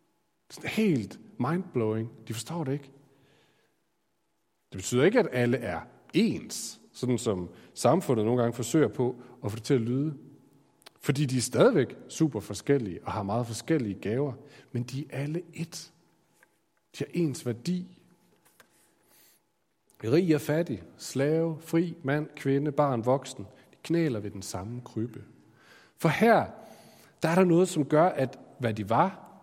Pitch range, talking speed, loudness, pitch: 120-160 Hz, 150 wpm, -29 LUFS, 140 Hz